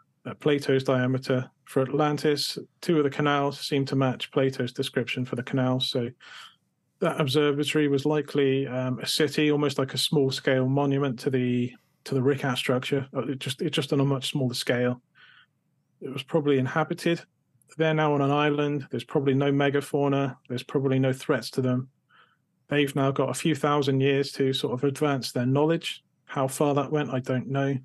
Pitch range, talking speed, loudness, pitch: 130-145 Hz, 185 wpm, -26 LUFS, 140 Hz